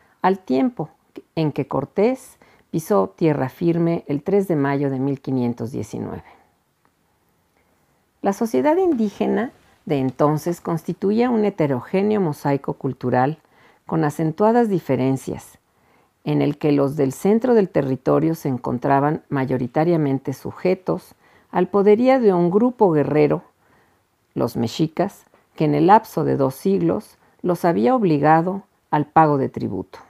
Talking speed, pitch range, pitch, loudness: 120 wpm, 140-195 Hz, 160 Hz, -20 LUFS